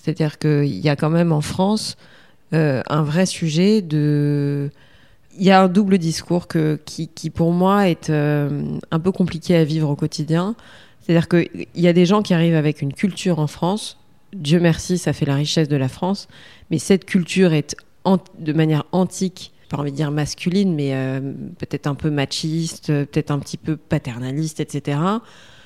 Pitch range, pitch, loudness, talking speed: 145-180 Hz, 160 Hz, -19 LUFS, 185 wpm